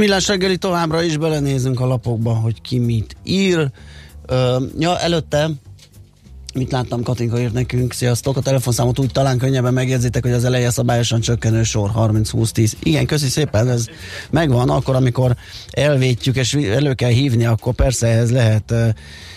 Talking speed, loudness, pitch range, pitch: 155 wpm, -17 LUFS, 115-135 Hz, 125 Hz